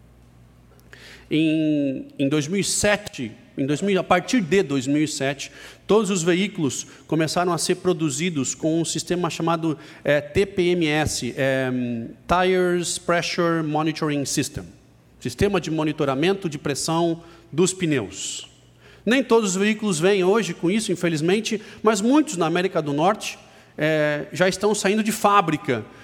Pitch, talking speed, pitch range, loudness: 165 Hz, 125 wpm, 145-190 Hz, -22 LUFS